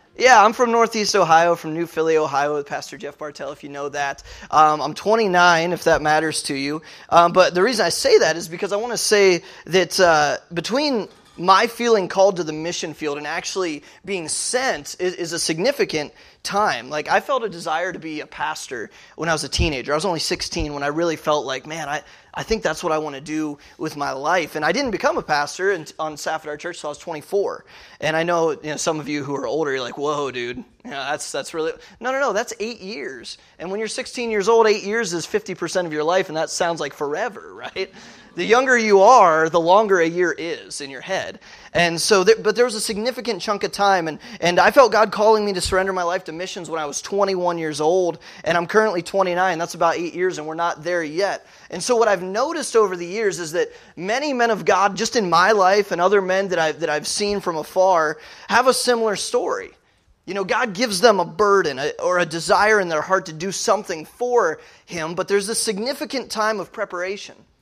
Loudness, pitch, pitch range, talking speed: -20 LUFS, 185 Hz, 160-215 Hz, 235 wpm